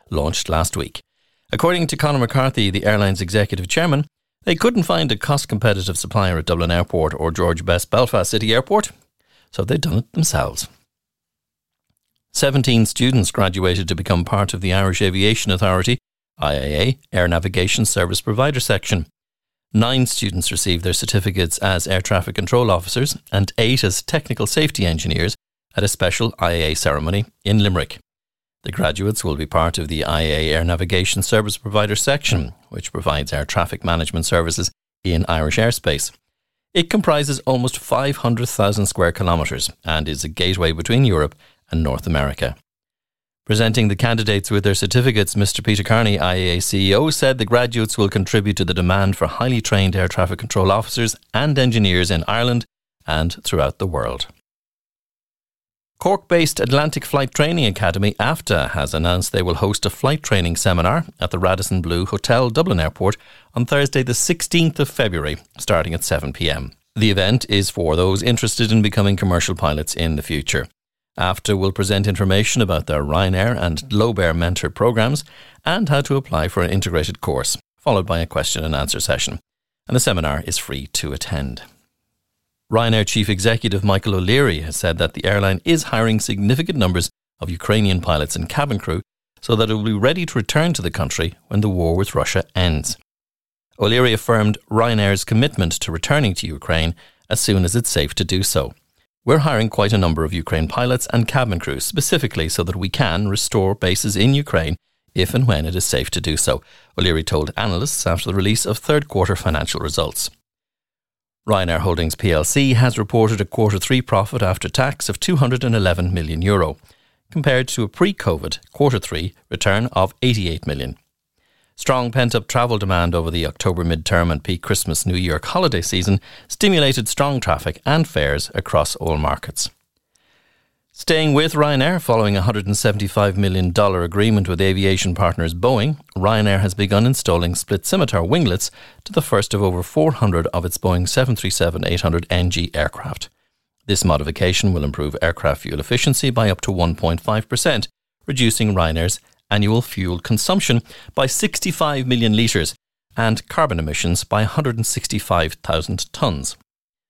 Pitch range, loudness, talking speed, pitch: 85-115 Hz, -18 LUFS, 160 wpm, 100 Hz